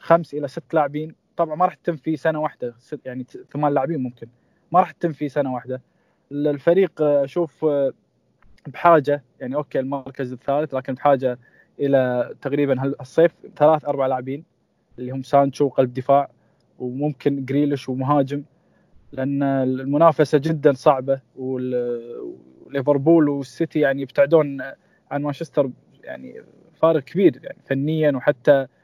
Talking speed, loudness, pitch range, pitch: 125 wpm, -21 LUFS, 135-155 Hz, 145 Hz